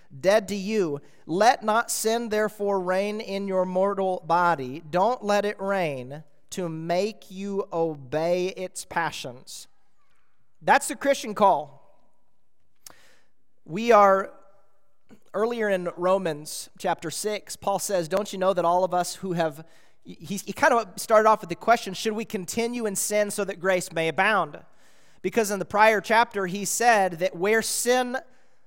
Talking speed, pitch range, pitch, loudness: 155 wpm, 180-215 Hz, 195 Hz, -24 LUFS